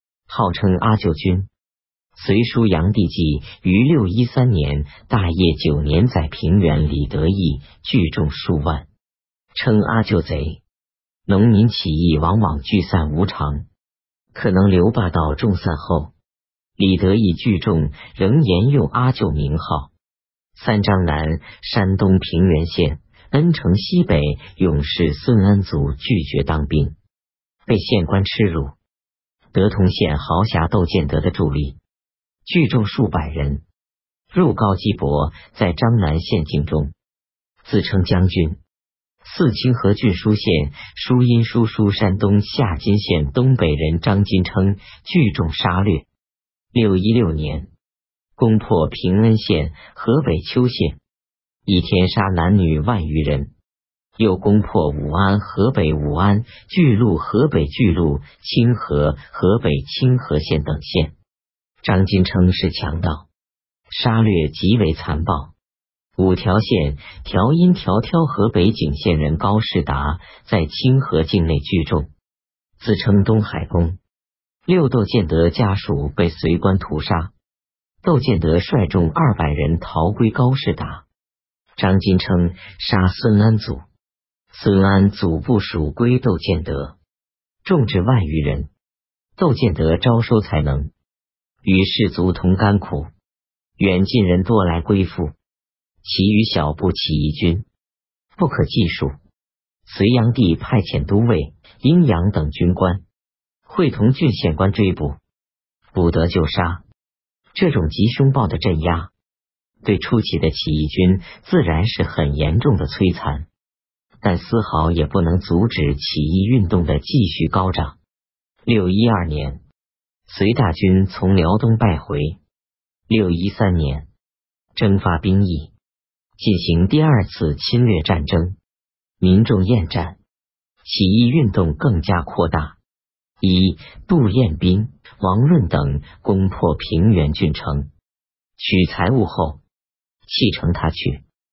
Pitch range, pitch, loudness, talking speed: 75-105 Hz, 90 Hz, -18 LUFS, 185 characters per minute